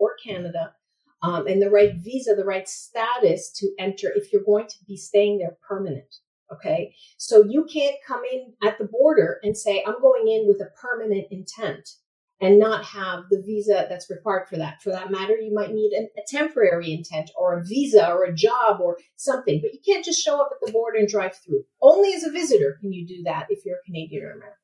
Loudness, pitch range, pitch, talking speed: -22 LUFS, 190-260 Hz, 210 Hz, 220 wpm